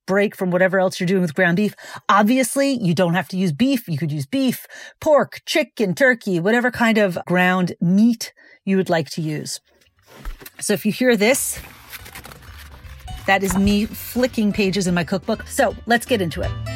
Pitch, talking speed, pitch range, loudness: 195 Hz, 185 wpm, 185-230 Hz, -19 LUFS